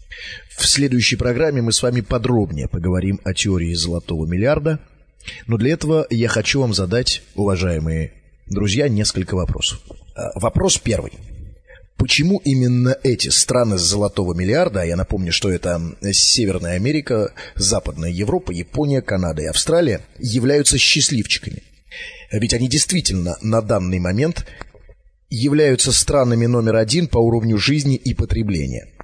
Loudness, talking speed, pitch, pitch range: -18 LUFS, 130 wpm, 110 Hz, 95-130 Hz